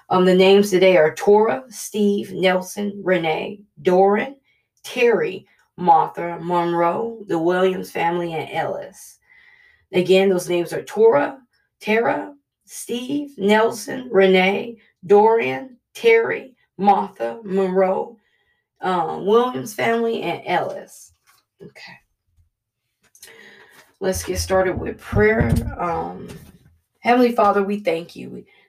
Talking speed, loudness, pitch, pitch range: 100 wpm, -19 LUFS, 200 Hz, 175-230 Hz